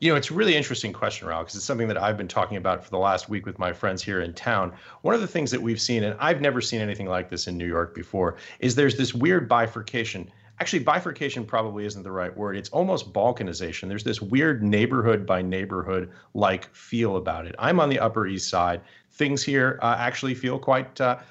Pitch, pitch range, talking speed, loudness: 110 Hz, 95-130 Hz, 230 wpm, -25 LUFS